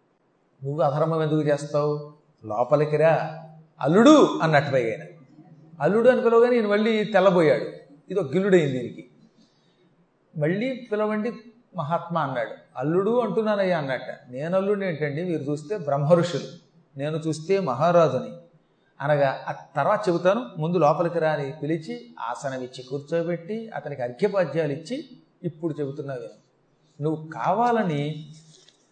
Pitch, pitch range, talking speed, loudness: 160 Hz, 150-190 Hz, 100 wpm, -23 LUFS